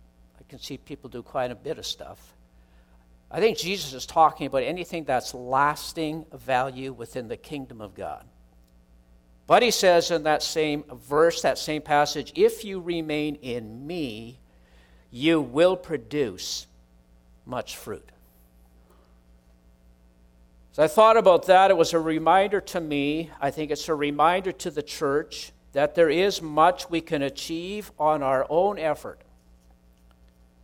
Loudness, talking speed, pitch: -24 LUFS, 145 wpm, 140 Hz